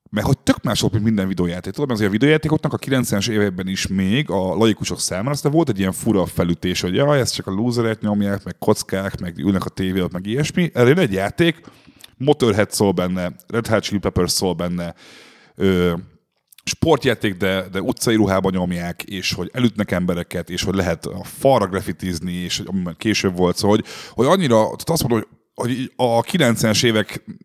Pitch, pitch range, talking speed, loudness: 100 Hz, 90-120 Hz, 185 wpm, -19 LUFS